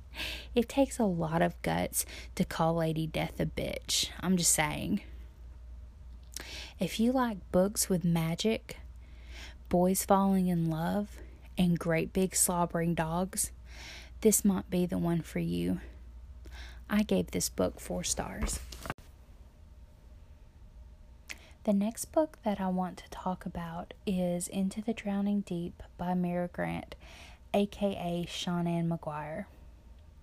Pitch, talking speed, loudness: 170 Hz, 125 wpm, -31 LUFS